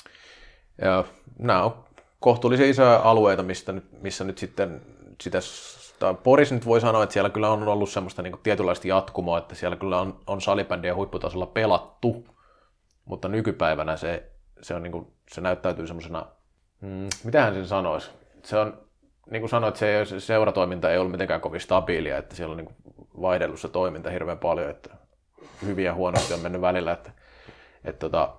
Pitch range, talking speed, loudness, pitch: 90-110 Hz, 155 wpm, -25 LUFS, 95 Hz